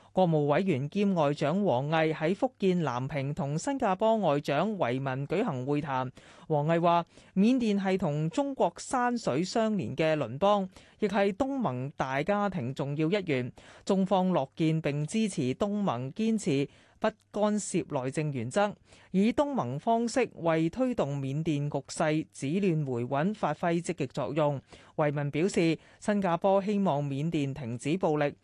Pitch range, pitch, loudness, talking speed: 145-205 Hz, 165 Hz, -29 LUFS, 230 characters per minute